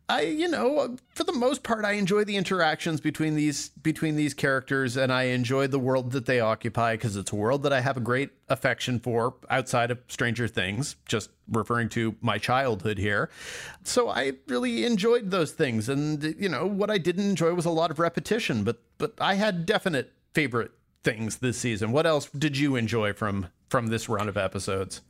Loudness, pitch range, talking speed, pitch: -27 LUFS, 115-170 Hz, 200 wpm, 135 Hz